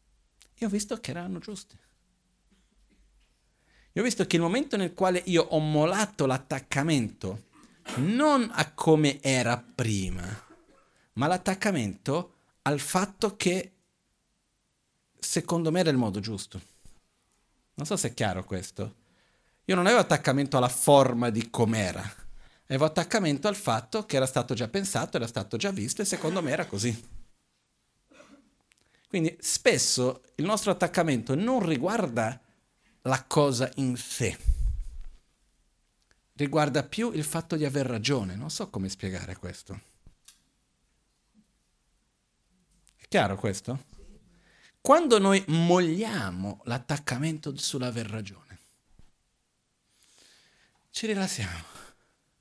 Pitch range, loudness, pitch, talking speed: 110-180 Hz, -27 LUFS, 140 Hz, 115 wpm